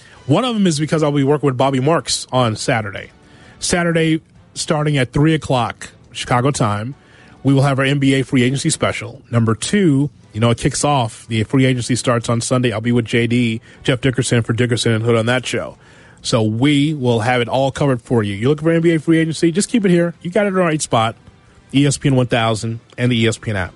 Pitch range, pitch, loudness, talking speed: 115-145 Hz, 130 Hz, -17 LUFS, 220 wpm